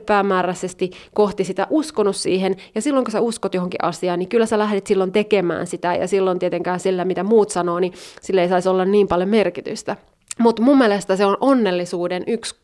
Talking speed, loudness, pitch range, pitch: 195 wpm, -19 LUFS, 180-210 Hz, 190 Hz